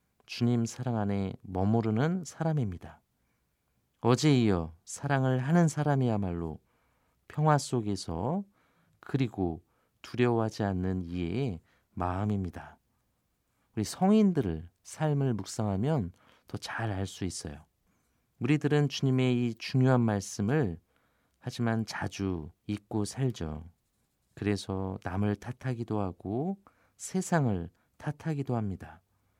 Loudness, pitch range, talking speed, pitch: -31 LUFS, 95-130 Hz, 235 characters per minute, 110 Hz